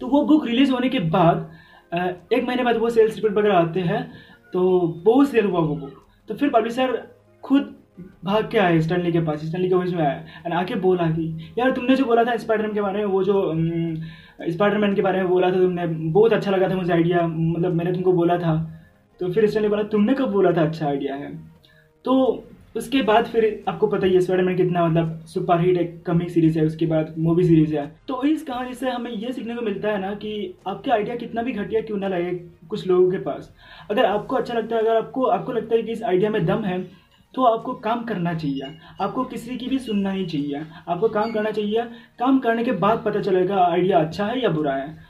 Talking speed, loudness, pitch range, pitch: 225 wpm, -21 LUFS, 170-225 Hz, 190 Hz